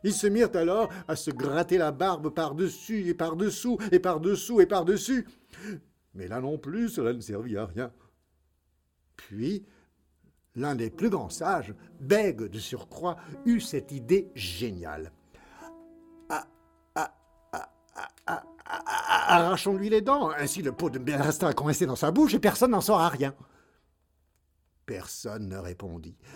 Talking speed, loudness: 155 wpm, -28 LUFS